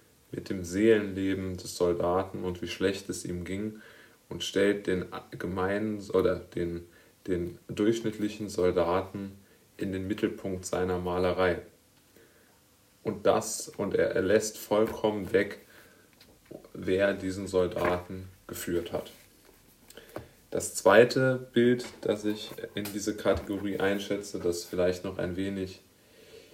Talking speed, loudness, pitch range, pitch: 120 wpm, -30 LUFS, 90-105 Hz, 95 Hz